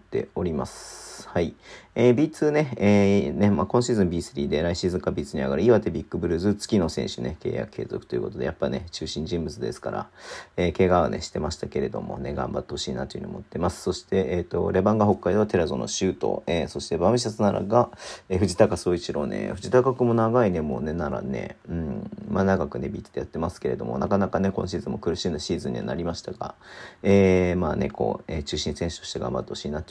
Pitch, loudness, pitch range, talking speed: 95 Hz, -25 LUFS, 90-105 Hz, 425 characters per minute